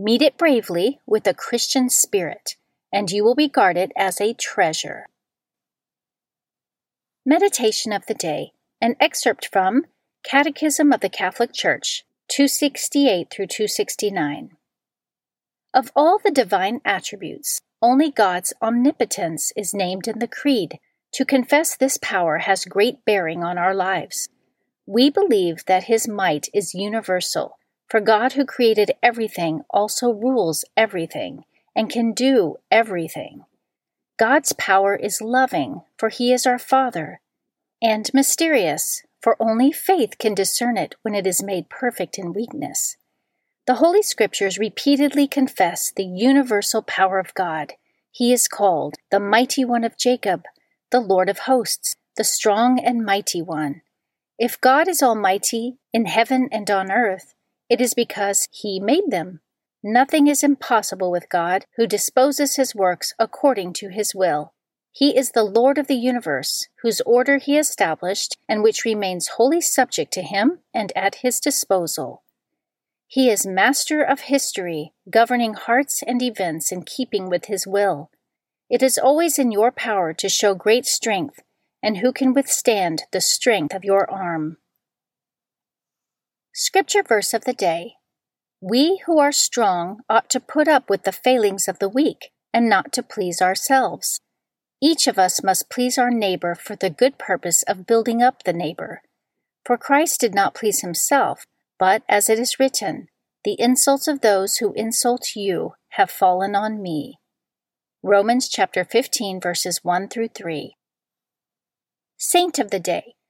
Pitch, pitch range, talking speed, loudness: 230 Hz, 195-265 Hz, 150 wpm, -19 LUFS